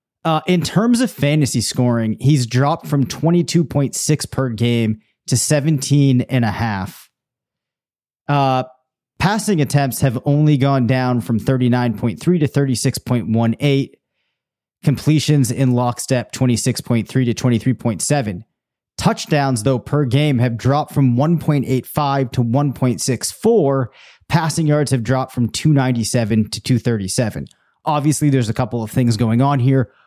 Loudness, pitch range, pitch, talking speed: -17 LUFS, 120-145 Hz, 130 Hz, 115 wpm